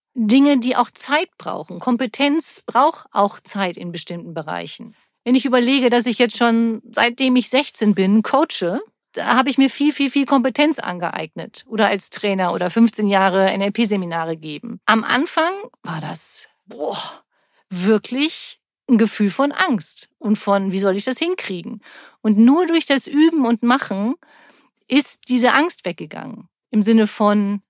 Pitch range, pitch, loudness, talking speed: 205-275 Hz, 235 Hz, -18 LUFS, 155 wpm